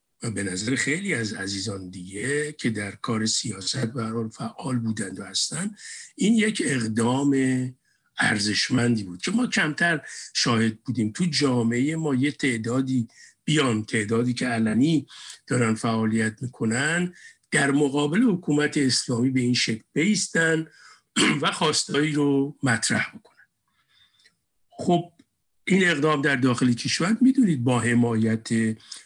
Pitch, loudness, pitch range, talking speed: 125 Hz, -24 LUFS, 115-150 Hz, 125 wpm